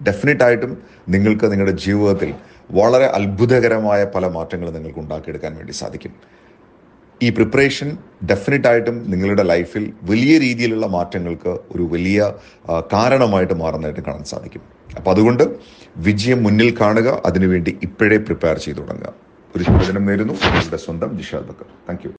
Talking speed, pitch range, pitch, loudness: 120 wpm, 90-115 Hz, 100 Hz, -17 LUFS